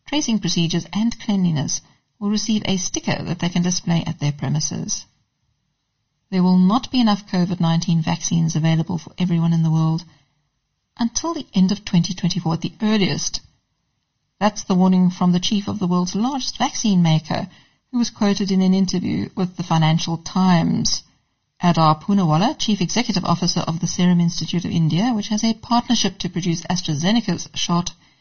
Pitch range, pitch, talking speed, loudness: 165-205 Hz, 180 Hz, 165 wpm, -20 LUFS